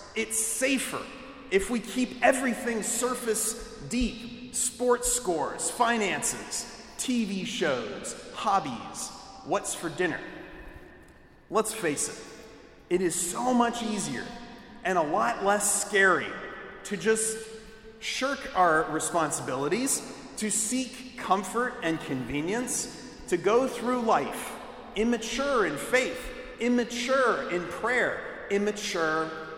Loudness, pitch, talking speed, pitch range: -28 LUFS, 235 Hz, 105 wpm, 205-250 Hz